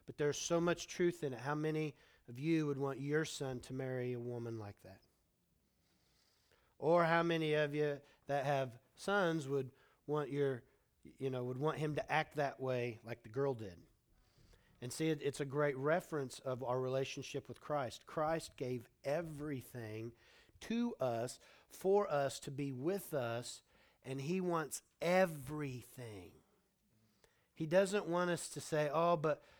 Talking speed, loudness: 160 wpm, -39 LUFS